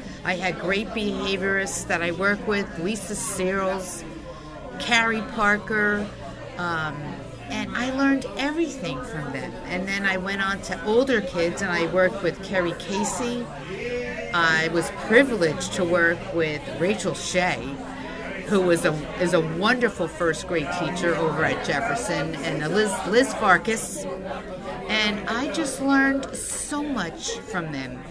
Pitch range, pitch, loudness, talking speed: 175-220 Hz, 195 Hz, -24 LUFS, 135 wpm